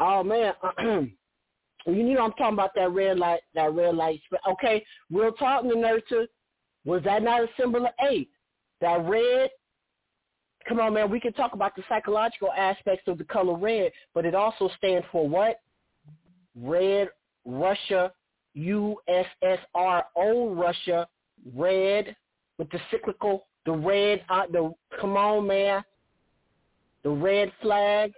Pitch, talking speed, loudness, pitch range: 195 Hz, 140 wpm, -26 LUFS, 175-220 Hz